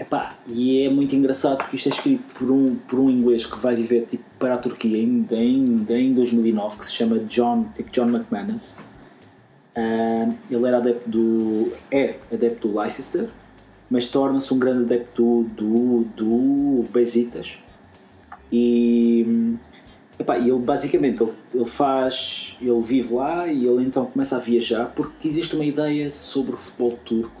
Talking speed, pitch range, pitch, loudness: 160 wpm, 115-135 Hz, 120 Hz, -21 LUFS